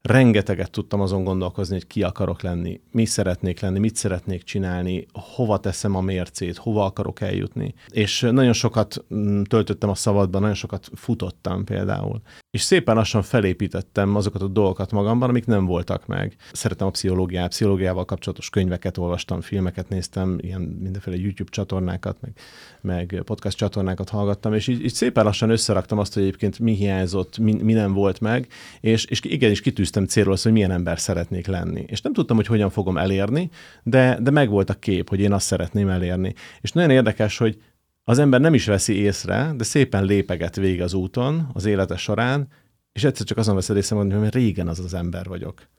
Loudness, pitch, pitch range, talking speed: -22 LUFS, 100 Hz, 95-110 Hz, 180 wpm